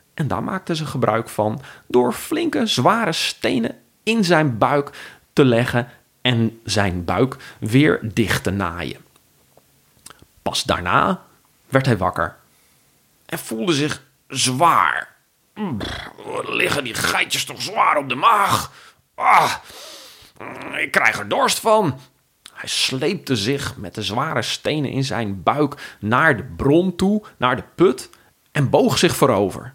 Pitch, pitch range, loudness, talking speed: 130 Hz, 115-155 Hz, -19 LUFS, 135 wpm